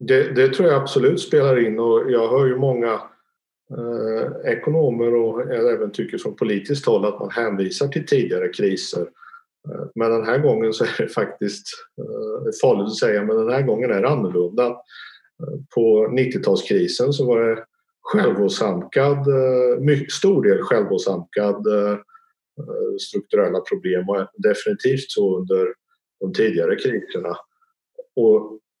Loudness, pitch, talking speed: -20 LUFS, 205 Hz, 145 wpm